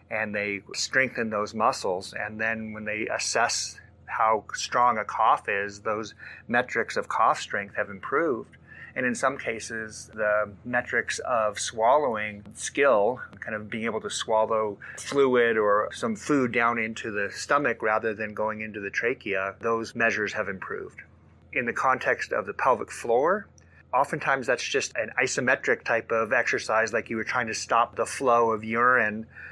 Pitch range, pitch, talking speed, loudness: 105-115 Hz, 110 Hz, 165 wpm, -26 LUFS